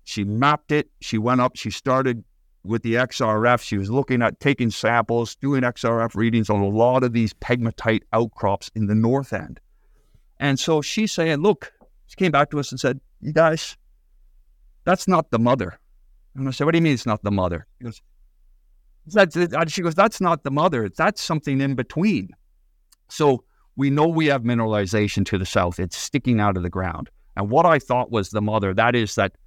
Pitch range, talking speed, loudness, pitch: 105-145 Hz, 200 wpm, -21 LUFS, 120 Hz